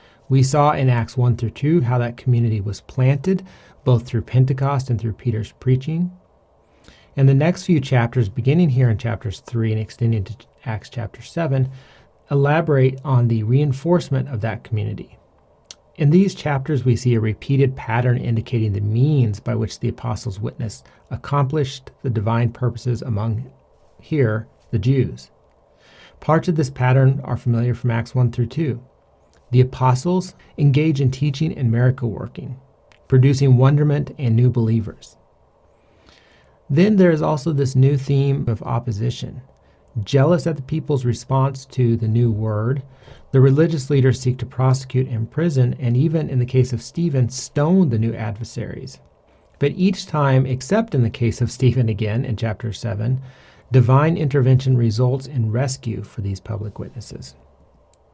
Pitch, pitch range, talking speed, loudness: 125 Hz, 115-140 Hz, 155 wpm, -19 LUFS